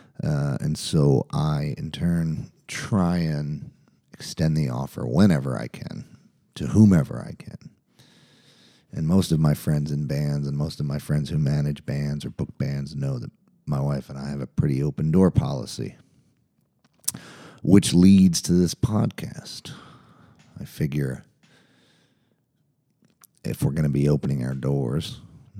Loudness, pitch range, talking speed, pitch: -23 LUFS, 70-95 Hz, 150 wpm, 75 Hz